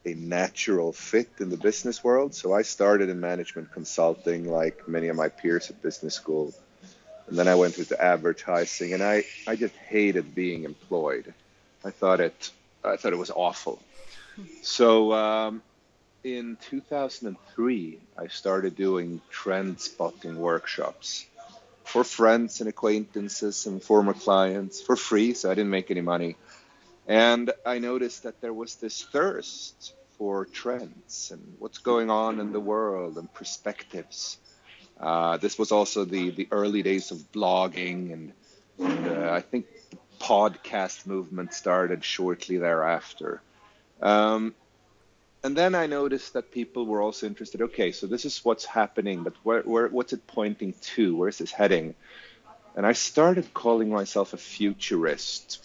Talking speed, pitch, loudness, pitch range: 150 wpm, 105 Hz, -27 LUFS, 90-115 Hz